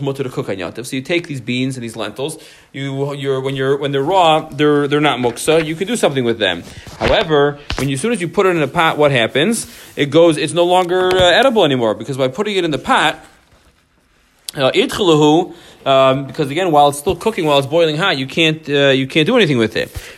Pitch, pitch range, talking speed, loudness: 145 Hz, 135-165 Hz, 225 wpm, -15 LUFS